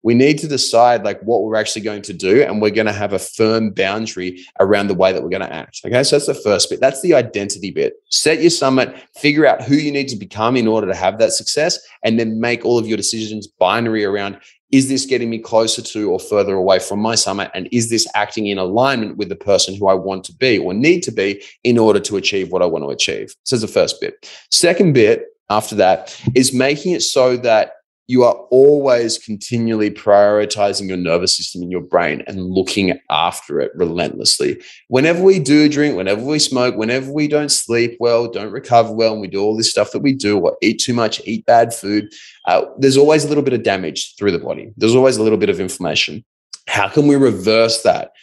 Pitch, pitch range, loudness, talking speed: 115 Hz, 105-140 Hz, -15 LUFS, 230 wpm